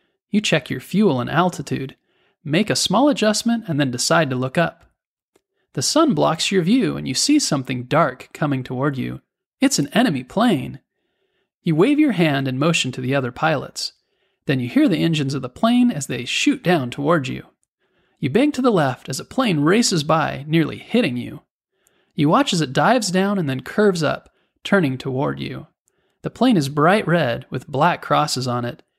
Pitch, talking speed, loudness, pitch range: 160 Hz, 195 wpm, -19 LUFS, 135-210 Hz